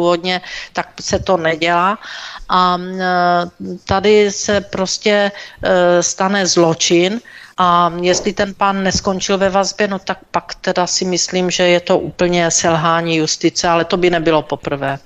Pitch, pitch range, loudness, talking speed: 180 Hz, 175-195 Hz, -15 LUFS, 135 wpm